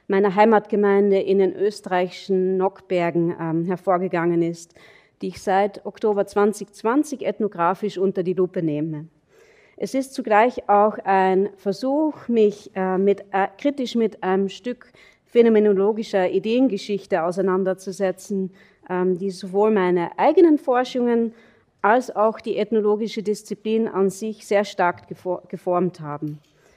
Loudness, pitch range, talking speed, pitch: -21 LUFS, 185-215 Hz, 120 wpm, 200 Hz